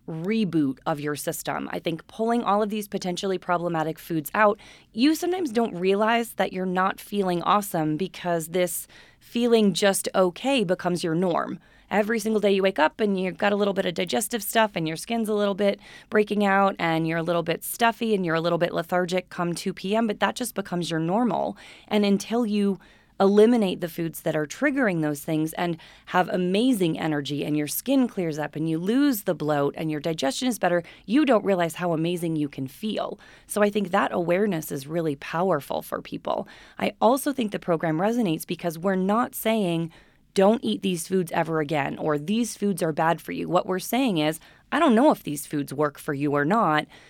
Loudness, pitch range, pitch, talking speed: -25 LUFS, 165-215 Hz, 185 Hz, 205 wpm